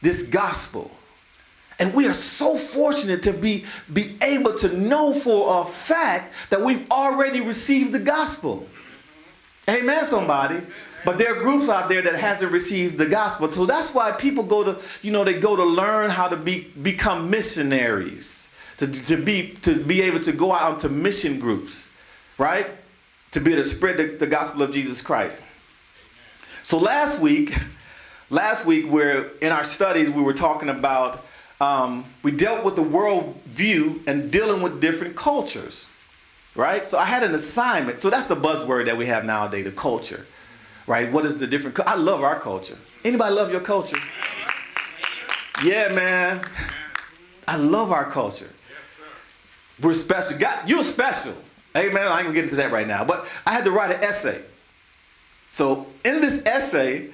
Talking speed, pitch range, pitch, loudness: 170 wpm, 155-245 Hz, 185 Hz, -21 LUFS